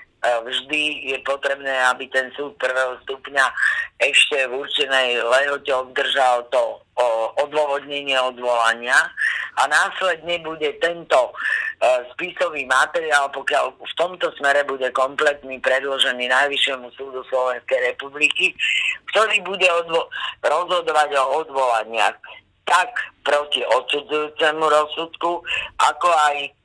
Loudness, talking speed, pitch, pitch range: -20 LUFS, 105 wpm, 145 Hz, 130-165 Hz